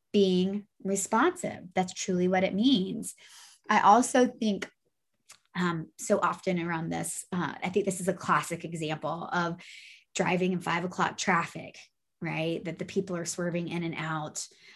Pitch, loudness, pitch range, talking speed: 185 Hz, -29 LUFS, 170-195 Hz, 155 wpm